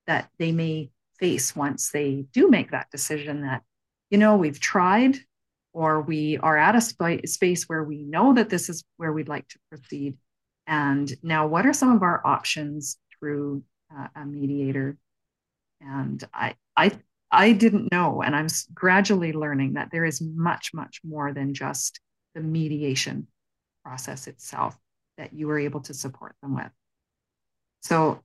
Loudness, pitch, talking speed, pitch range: -24 LUFS, 155 Hz, 160 wpm, 140-170 Hz